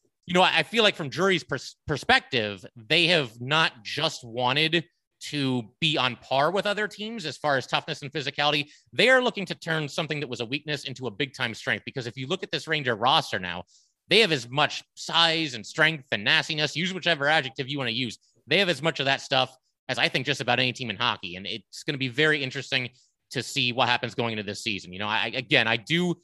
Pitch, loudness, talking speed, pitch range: 140 Hz, -25 LUFS, 235 wpm, 120-160 Hz